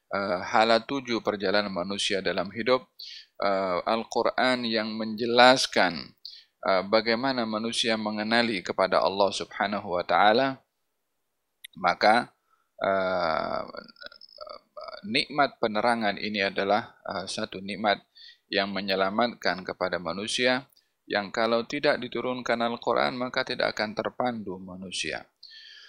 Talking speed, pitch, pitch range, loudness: 90 wpm, 115 Hz, 105-130 Hz, -26 LUFS